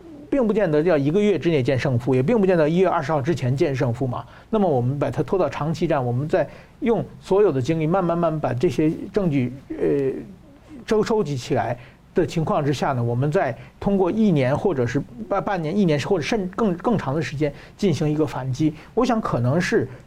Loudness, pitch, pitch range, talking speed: -22 LUFS, 160 Hz, 140-195 Hz, 315 characters per minute